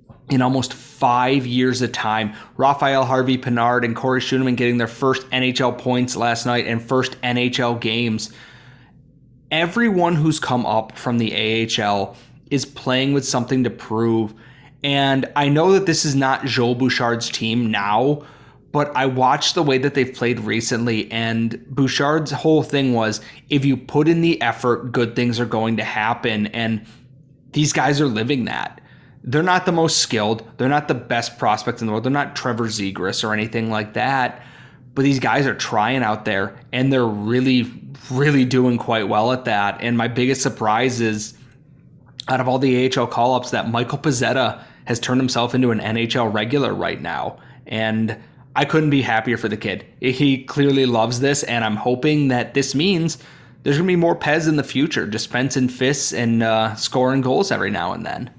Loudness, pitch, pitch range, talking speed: -19 LUFS, 125 Hz, 115-140 Hz, 180 wpm